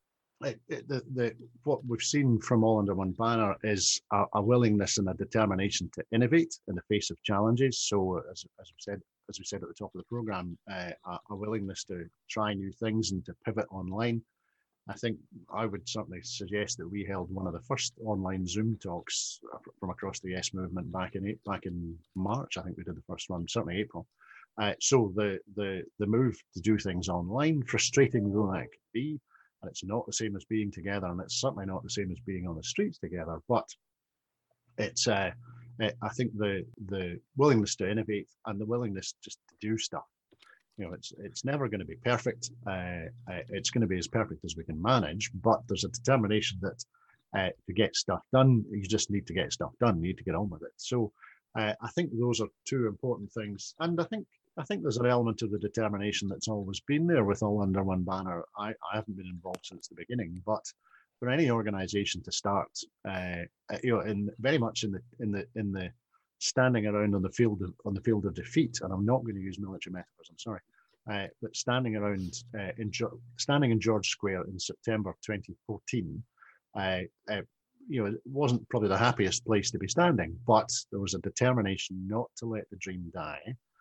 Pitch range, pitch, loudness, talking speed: 95-120 Hz, 105 Hz, -32 LUFS, 210 wpm